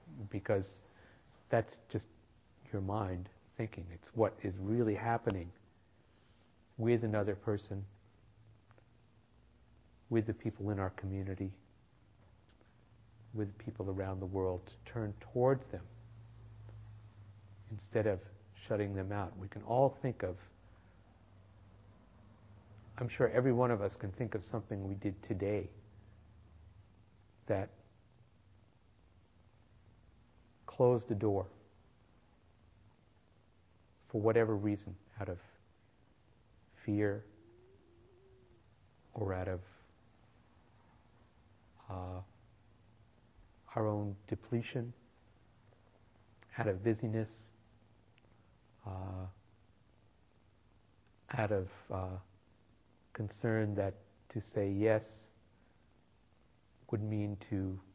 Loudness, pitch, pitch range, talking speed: -38 LUFS, 105 Hz, 100-110 Hz, 85 wpm